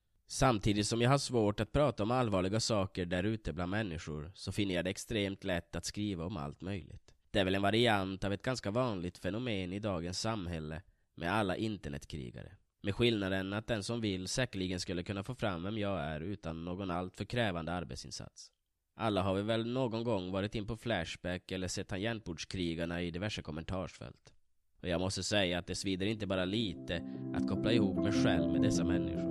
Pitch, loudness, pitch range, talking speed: 95 Hz, -35 LUFS, 85-110 Hz, 190 wpm